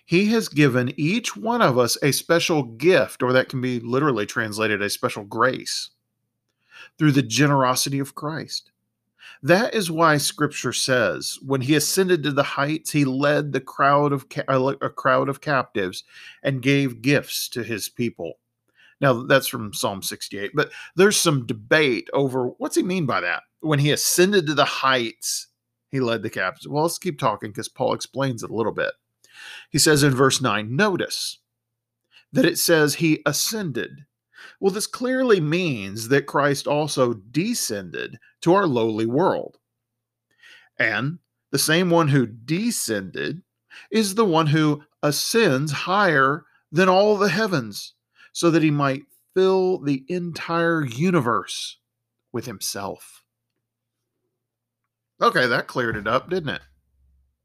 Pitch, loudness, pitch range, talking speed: 140 Hz, -21 LUFS, 120-165 Hz, 150 wpm